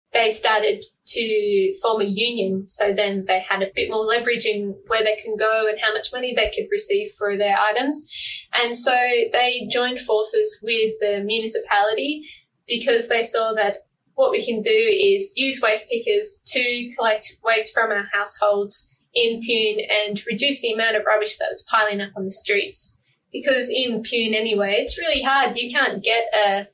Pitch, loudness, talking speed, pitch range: 230 Hz, -20 LUFS, 180 wpm, 215-280 Hz